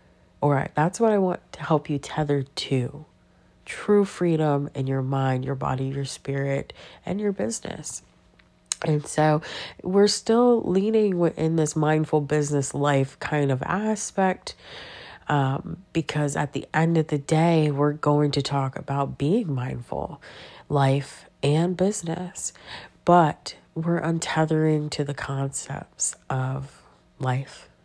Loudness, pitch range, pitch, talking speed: -24 LUFS, 140-170 Hz, 150 Hz, 135 wpm